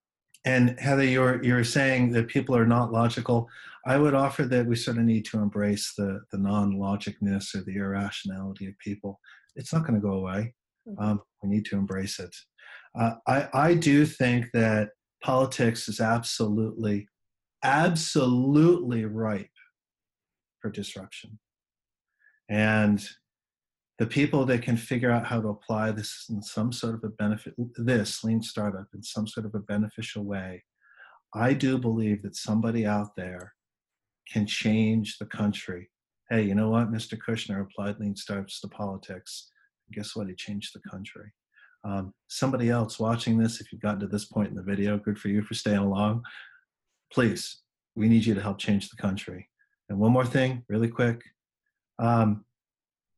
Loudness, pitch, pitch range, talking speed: -27 LUFS, 110 Hz, 100-120 Hz, 160 wpm